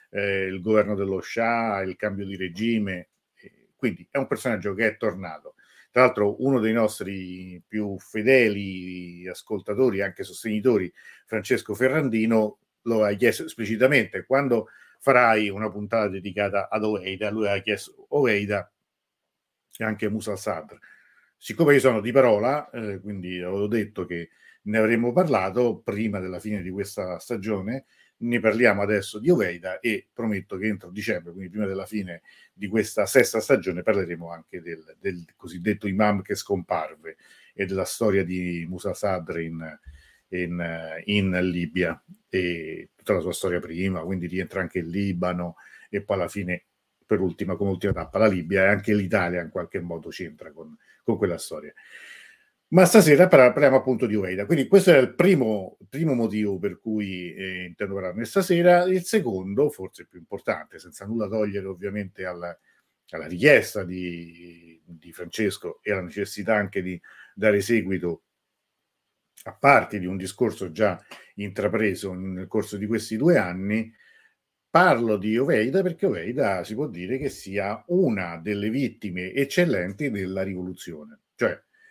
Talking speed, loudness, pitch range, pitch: 150 wpm, -24 LUFS, 95-115 Hz, 105 Hz